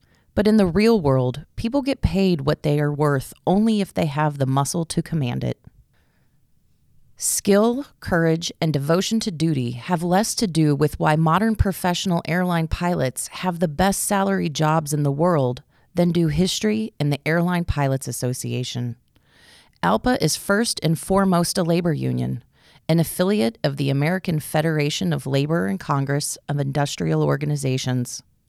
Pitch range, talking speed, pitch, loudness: 140-185 Hz, 155 wpm, 160 Hz, -21 LUFS